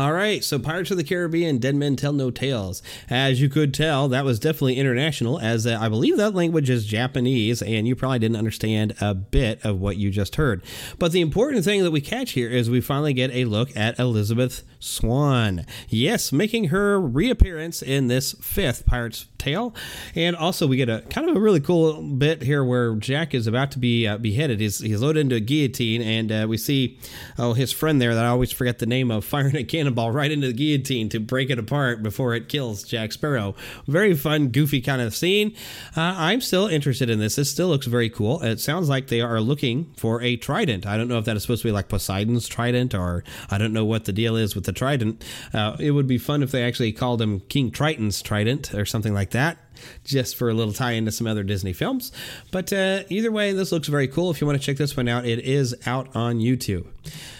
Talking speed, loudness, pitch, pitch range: 230 wpm, -23 LUFS, 125 Hz, 115-150 Hz